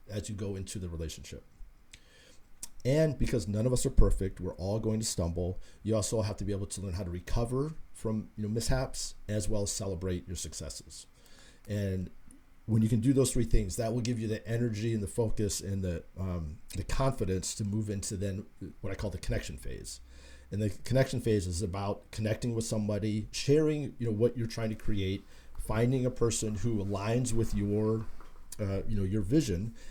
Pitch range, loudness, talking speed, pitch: 95-115 Hz, -33 LUFS, 200 wpm, 105 Hz